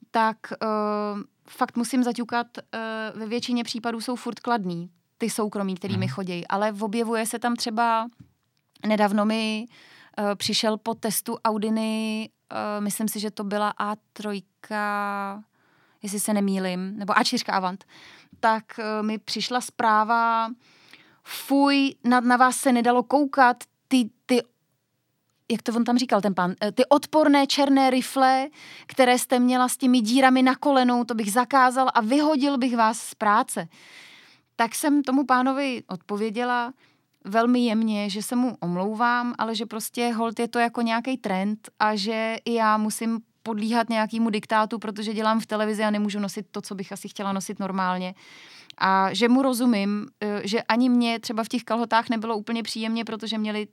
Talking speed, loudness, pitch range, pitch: 155 wpm, -24 LUFS, 210-245 Hz, 225 Hz